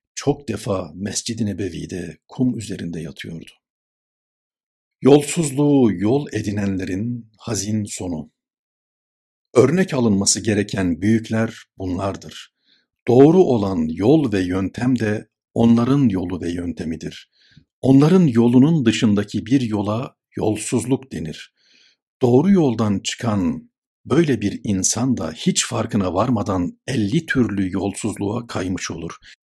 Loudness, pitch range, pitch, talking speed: -19 LUFS, 100-130 Hz, 115 Hz, 100 wpm